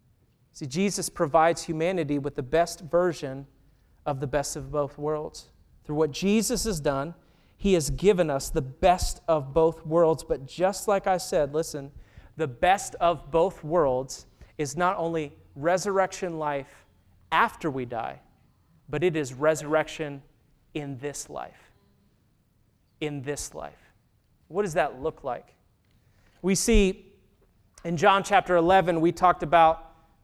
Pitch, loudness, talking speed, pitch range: 160 Hz, -26 LUFS, 140 wpm, 145-180 Hz